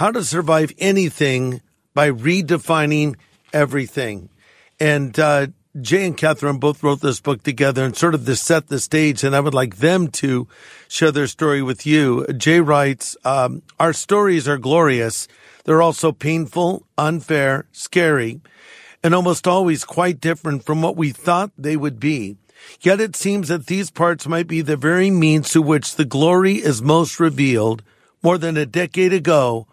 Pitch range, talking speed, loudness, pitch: 140-170 Hz, 165 wpm, -18 LUFS, 155 Hz